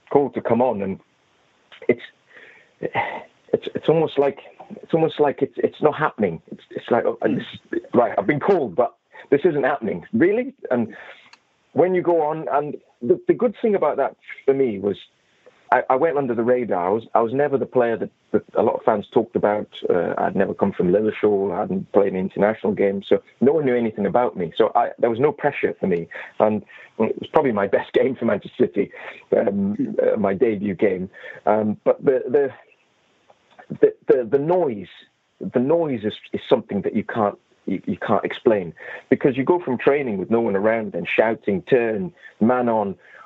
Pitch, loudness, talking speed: 155 Hz, -21 LUFS, 200 wpm